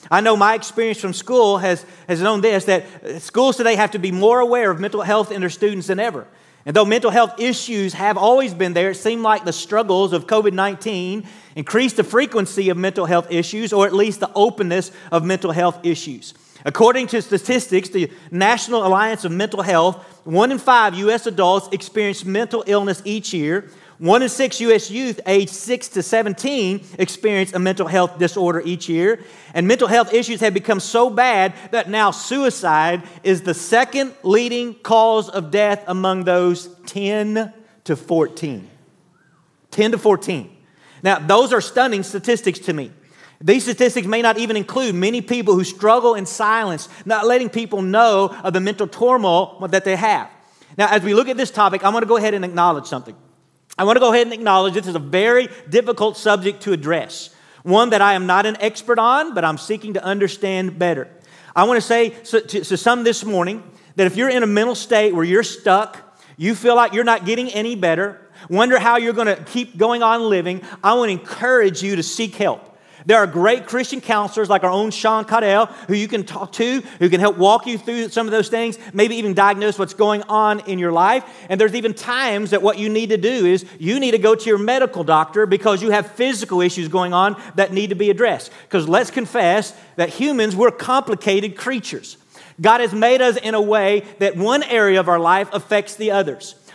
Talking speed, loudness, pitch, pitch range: 205 wpm, -17 LUFS, 205 Hz, 185-230 Hz